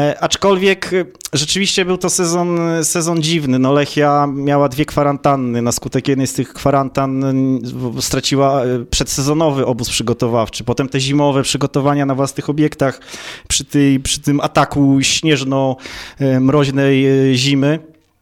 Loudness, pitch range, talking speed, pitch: -15 LUFS, 135-150 Hz, 120 wpm, 140 Hz